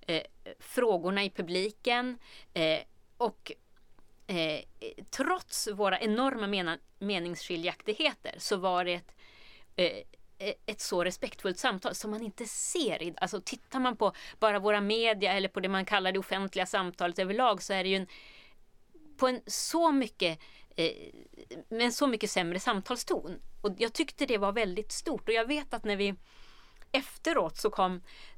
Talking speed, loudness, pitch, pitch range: 155 wpm, -31 LUFS, 210 Hz, 190-250 Hz